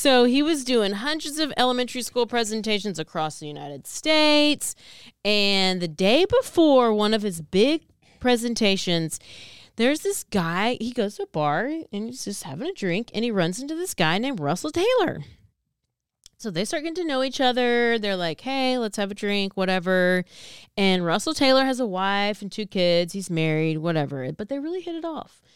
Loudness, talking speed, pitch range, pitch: -23 LUFS, 185 wpm, 185-265 Hz, 215 Hz